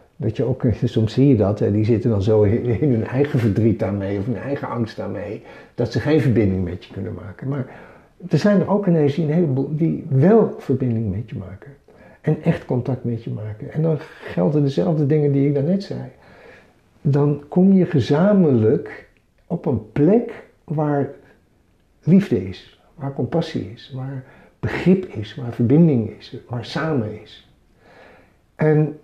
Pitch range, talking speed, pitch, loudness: 110-150 Hz, 175 wpm, 130 Hz, -20 LUFS